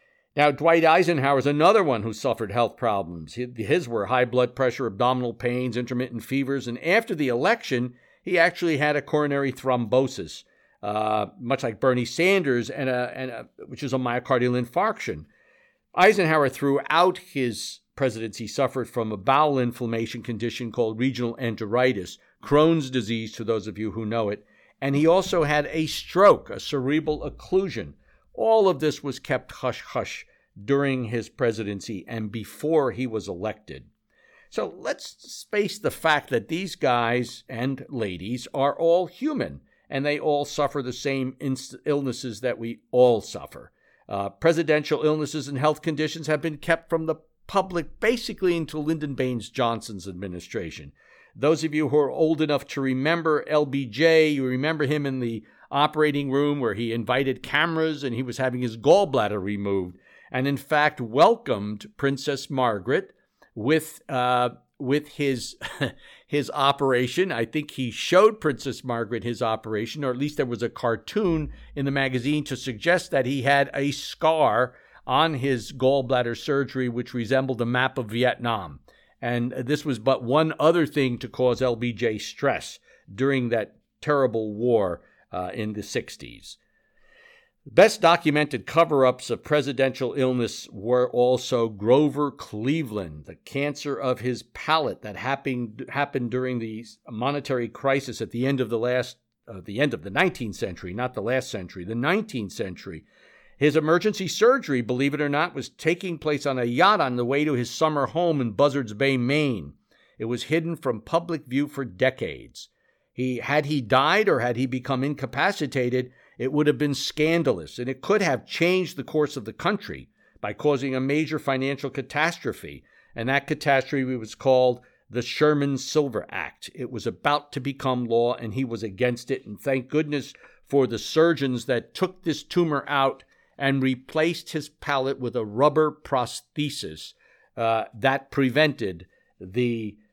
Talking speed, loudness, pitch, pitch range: 160 wpm, -24 LUFS, 135 Hz, 120-150 Hz